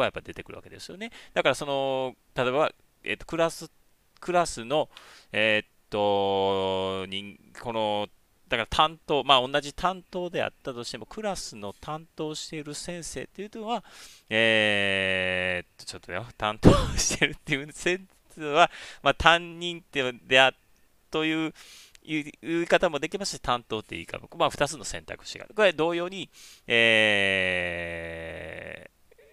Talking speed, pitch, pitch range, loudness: 305 characters per minute, 130 Hz, 100-165 Hz, -26 LUFS